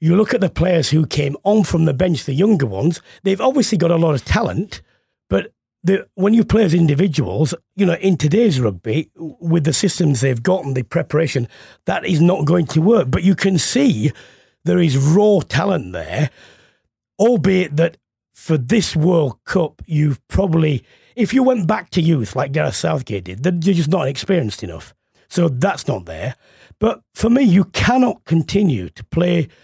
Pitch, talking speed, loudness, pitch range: 170 Hz, 185 wpm, -17 LUFS, 145-195 Hz